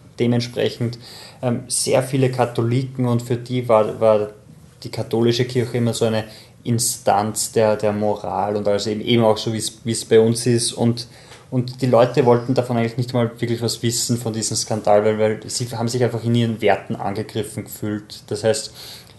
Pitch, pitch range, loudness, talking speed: 115 Hz, 110-125 Hz, -20 LUFS, 185 wpm